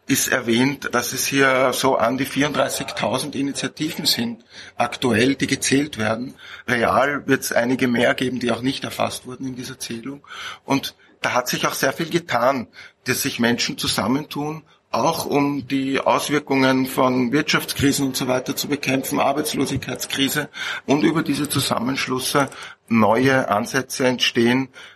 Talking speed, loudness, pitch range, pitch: 145 wpm, -20 LUFS, 125-140 Hz, 135 Hz